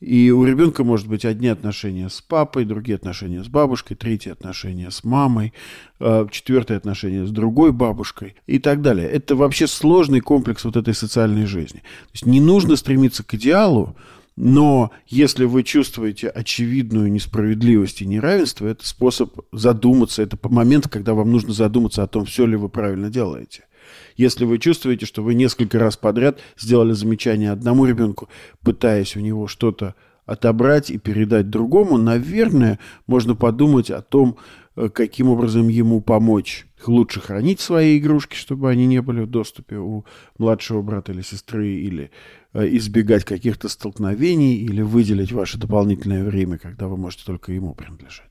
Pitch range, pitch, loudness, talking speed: 105-125 Hz, 115 Hz, -18 LUFS, 155 wpm